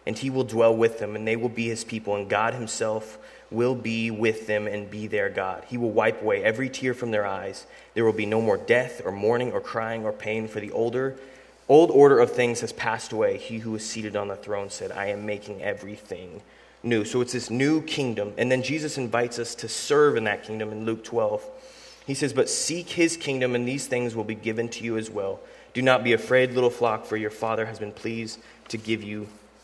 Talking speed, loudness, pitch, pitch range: 235 wpm, -25 LUFS, 115 Hz, 110-130 Hz